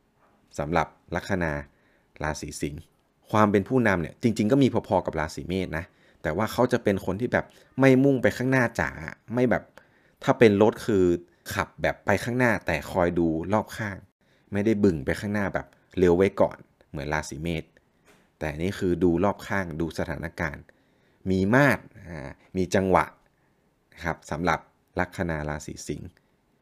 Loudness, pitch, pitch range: -26 LUFS, 95 Hz, 80-105 Hz